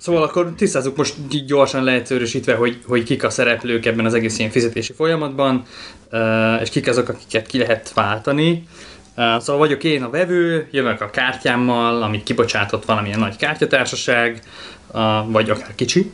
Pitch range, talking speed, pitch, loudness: 115-145 Hz, 150 wpm, 120 Hz, -18 LUFS